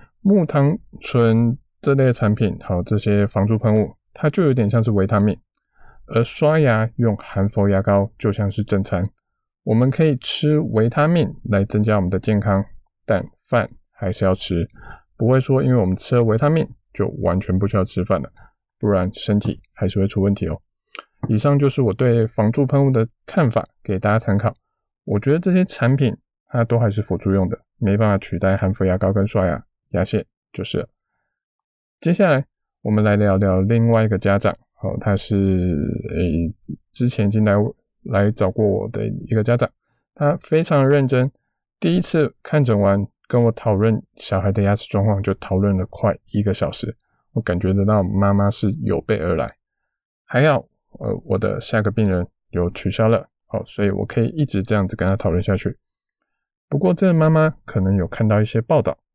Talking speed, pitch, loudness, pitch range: 265 characters per minute, 105 Hz, -19 LUFS, 95-120 Hz